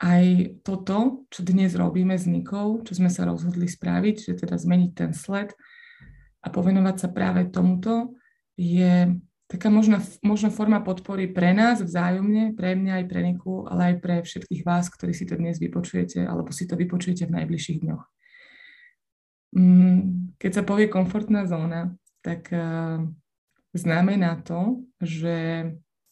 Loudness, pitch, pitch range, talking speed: -24 LUFS, 180 Hz, 175-200 Hz, 140 wpm